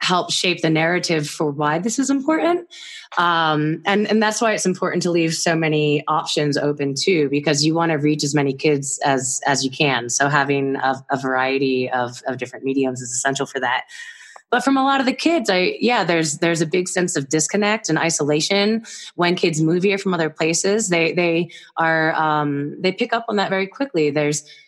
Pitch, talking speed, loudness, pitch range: 160 Hz, 205 wpm, -19 LUFS, 145-195 Hz